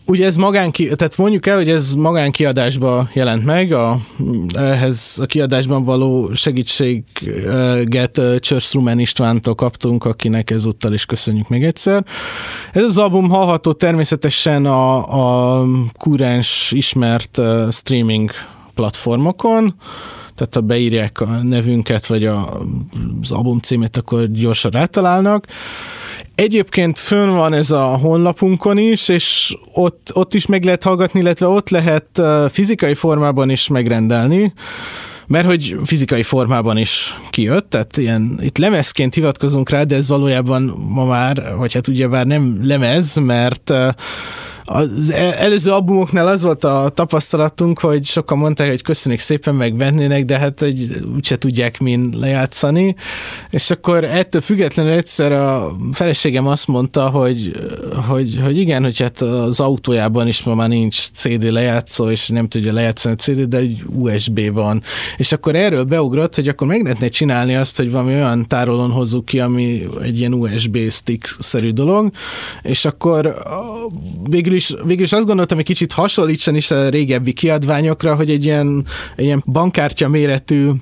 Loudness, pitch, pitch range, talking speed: -15 LUFS, 135 Hz, 120-165 Hz, 145 wpm